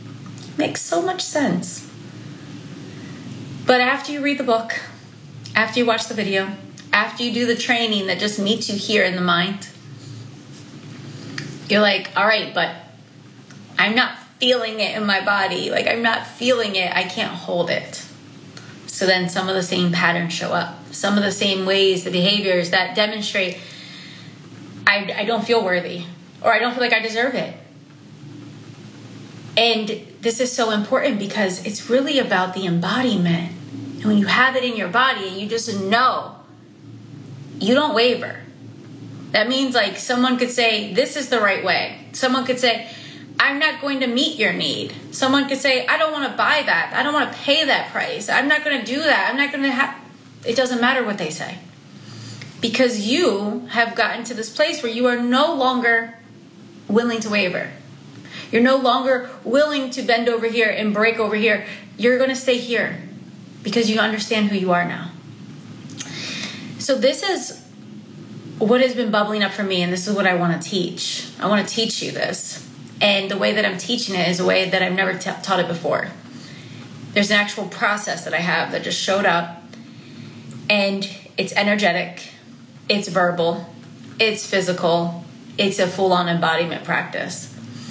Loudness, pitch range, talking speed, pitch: -19 LUFS, 185-245 Hz, 180 wpm, 210 Hz